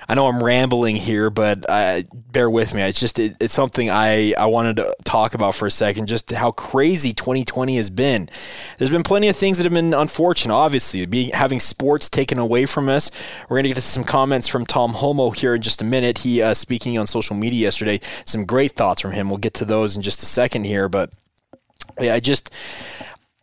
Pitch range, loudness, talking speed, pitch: 110-135 Hz, -18 LUFS, 220 wpm, 120 Hz